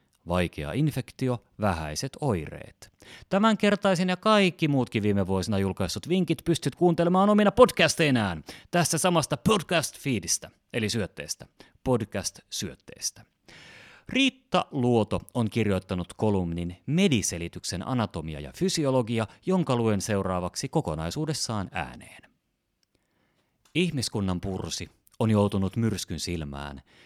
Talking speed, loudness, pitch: 100 wpm, -26 LUFS, 115 Hz